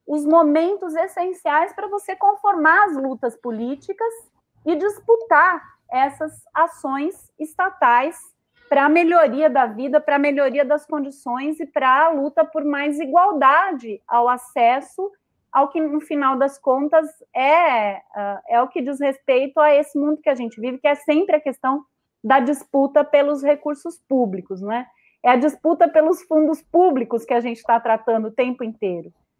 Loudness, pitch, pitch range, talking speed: -19 LUFS, 295 Hz, 260-325 Hz, 155 wpm